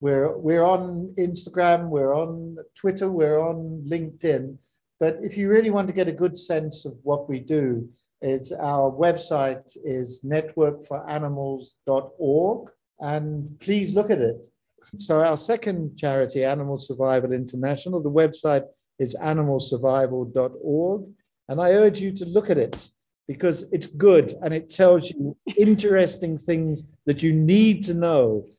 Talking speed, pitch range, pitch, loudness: 140 wpm, 140-180 Hz, 155 Hz, -23 LUFS